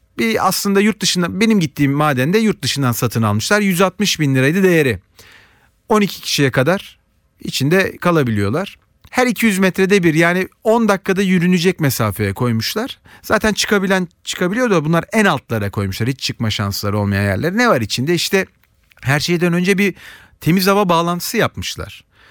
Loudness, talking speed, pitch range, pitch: -16 LUFS, 150 wpm, 125-195 Hz, 170 Hz